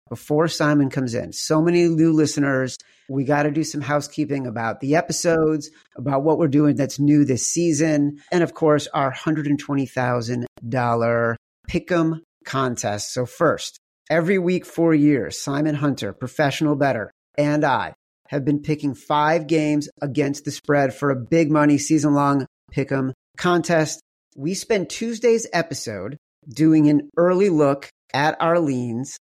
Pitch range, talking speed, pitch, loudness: 135-160 Hz, 150 wpm, 150 Hz, -21 LUFS